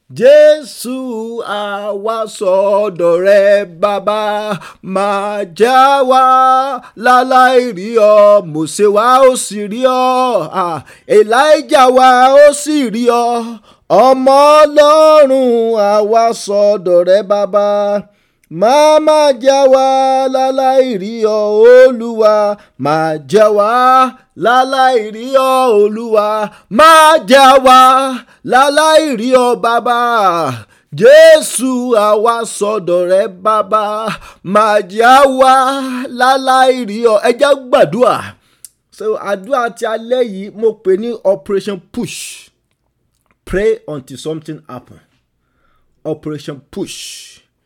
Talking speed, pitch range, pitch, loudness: 95 wpm, 205-260 Hz, 230 Hz, -10 LUFS